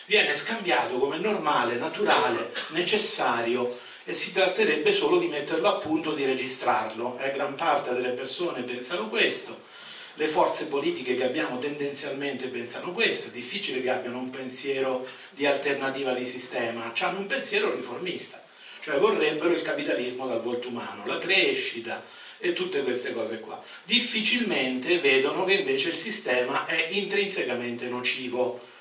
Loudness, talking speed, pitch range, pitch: -26 LUFS, 140 wpm, 125-205 Hz, 140 Hz